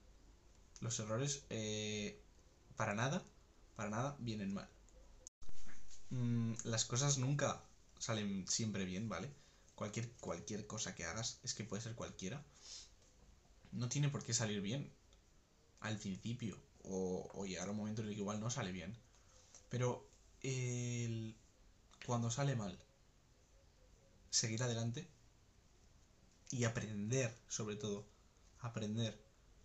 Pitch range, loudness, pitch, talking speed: 95-115 Hz, -43 LUFS, 110 Hz, 120 wpm